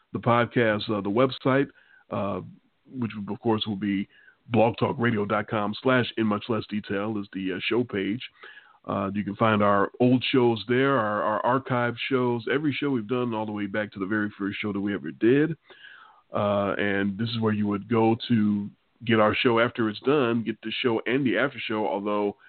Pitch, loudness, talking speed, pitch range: 110 Hz, -25 LUFS, 200 wpm, 105-120 Hz